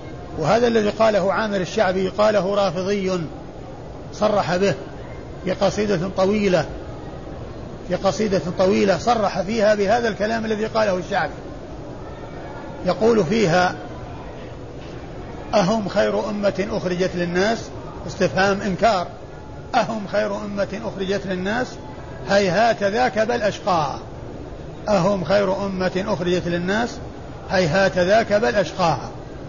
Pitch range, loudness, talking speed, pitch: 185-210 Hz, -20 LUFS, 95 wpm, 195 Hz